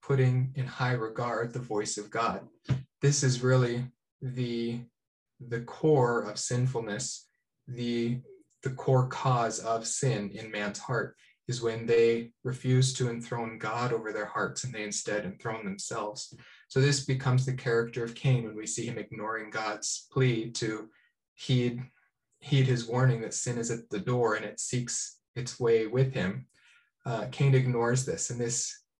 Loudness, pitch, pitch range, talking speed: -30 LUFS, 120 Hz, 115-130 Hz, 160 wpm